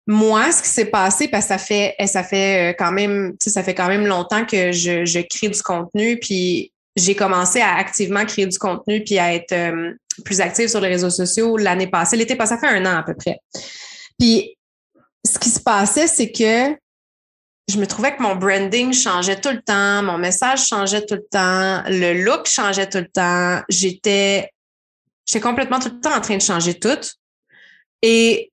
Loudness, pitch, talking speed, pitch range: -17 LUFS, 200 Hz, 195 wpm, 185-225 Hz